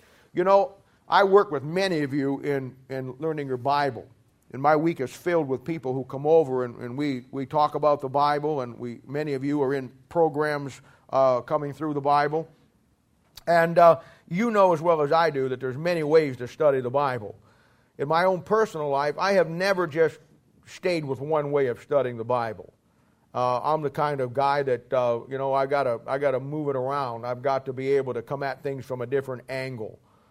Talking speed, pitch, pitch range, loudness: 215 wpm, 140 Hz, 130-160 Hz, -25 LUFS